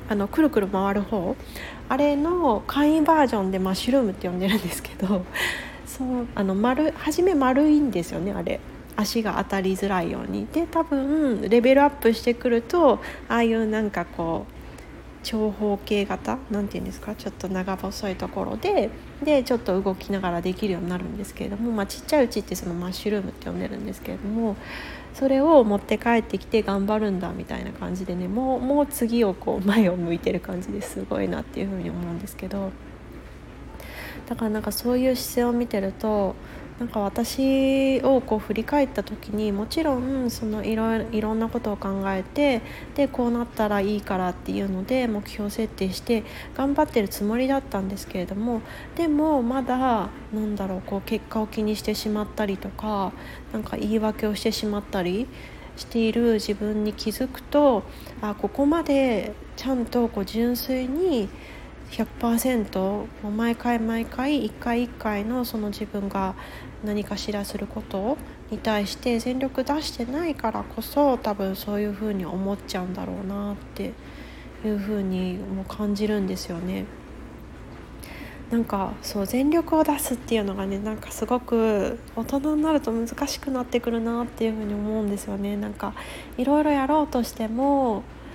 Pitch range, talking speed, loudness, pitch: 200-255 Hz, 355 characters per minute, -25 LUFS, 220 Hz